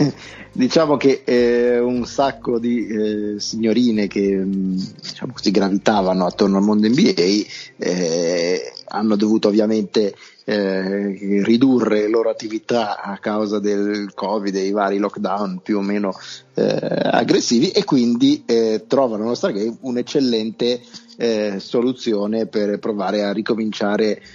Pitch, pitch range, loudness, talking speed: 110 Hz, 105-120 Hz, -19 LUFS, 130 wpm